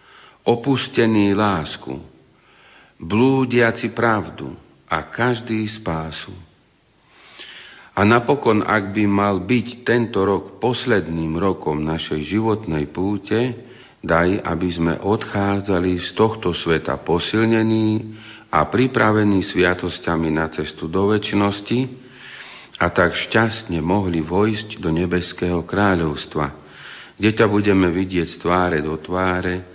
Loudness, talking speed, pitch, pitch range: -20 LUFS, 105 wpm, 95 Hz, 85-110 Hz